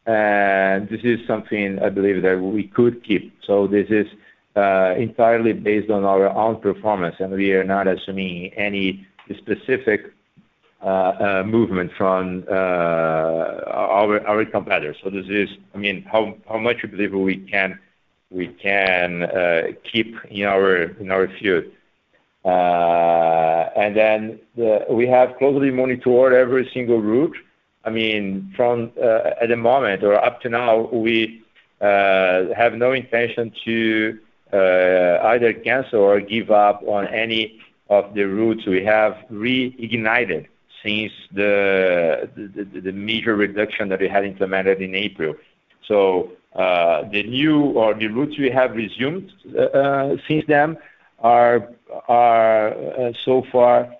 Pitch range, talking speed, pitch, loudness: 95-115 Hz, 140 wpm, 105 Hz, -19 LUFS